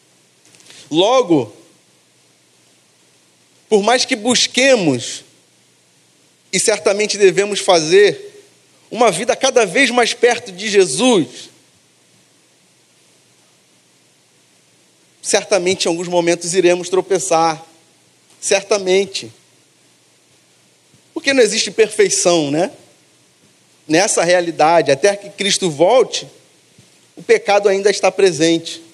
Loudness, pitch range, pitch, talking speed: -14 LUFS, 170-235 Hz, 195 Hz, 85 wpm